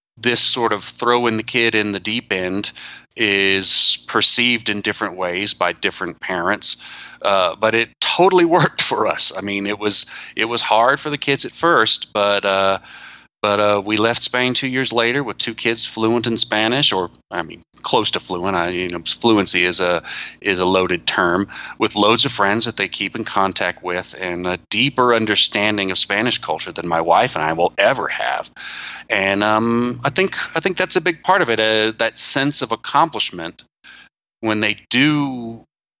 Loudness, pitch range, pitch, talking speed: -17 LUFS, 100-120 Hz, 110 Hz, 190 wpm